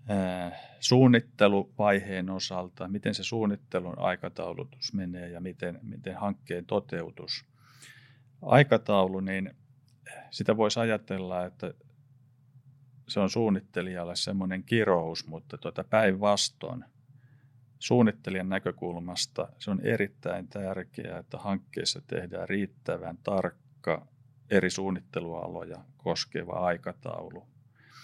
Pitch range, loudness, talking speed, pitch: 95-130 Hz, -30 LUFS, 90 wpm, 105 Hz